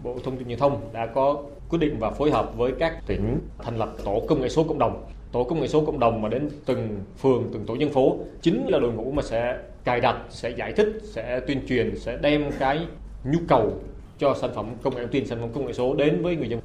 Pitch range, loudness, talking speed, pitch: 120-150 Hz, -25 LUFS, 260 wpm, 130 Hz